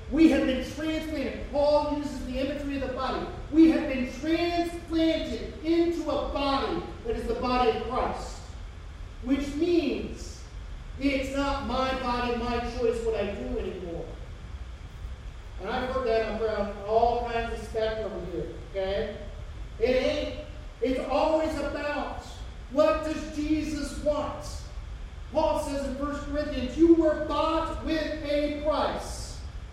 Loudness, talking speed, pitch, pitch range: -28 LUFS, 135 wpm, 280 Hz, 235-305 Hz